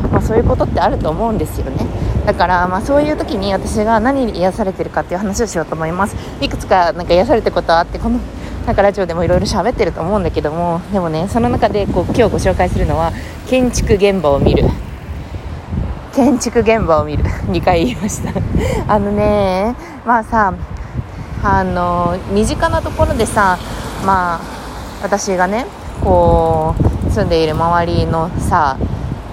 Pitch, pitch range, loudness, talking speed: 185 Hz, 160-210 Hz, -15 LUFS, 345 characters per minute